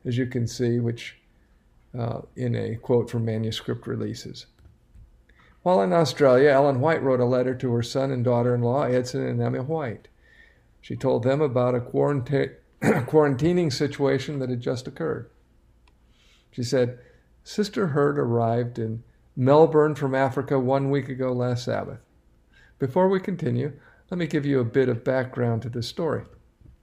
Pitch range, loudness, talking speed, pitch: 120-140 Hz, -24 LUFS, 160 wpm, 130 Hz